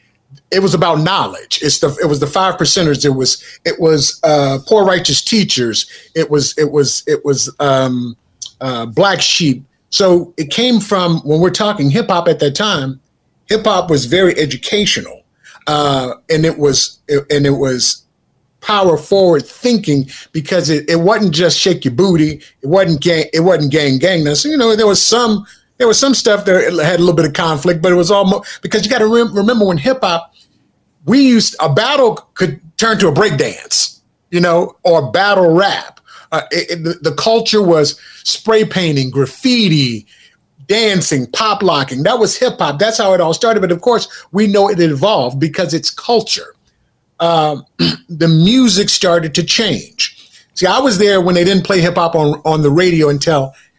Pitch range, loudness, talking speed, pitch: 145-200 Hz, -12 LUFS, 190 wpm, 170 Hz